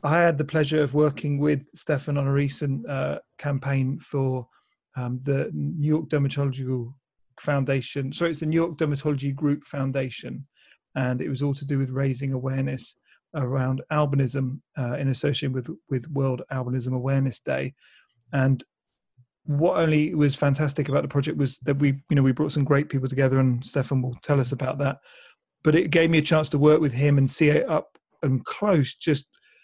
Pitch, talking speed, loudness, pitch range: 140 Hz, 185 wpm, -25 LUFS, 130-150 Hz